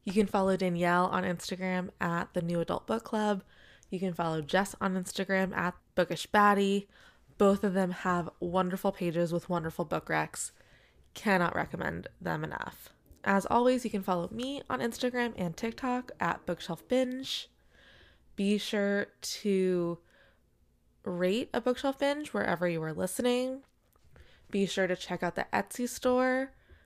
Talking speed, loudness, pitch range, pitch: 150 wpm, -31 LUFS, 180-230 Hz, 195 Hz